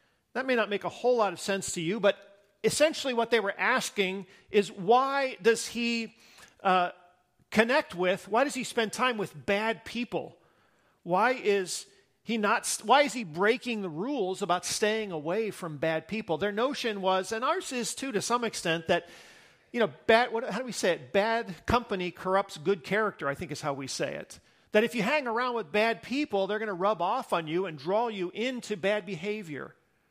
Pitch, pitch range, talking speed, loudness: 210 Hz, 185-235 Hz, 200 wpm, -29 LUFS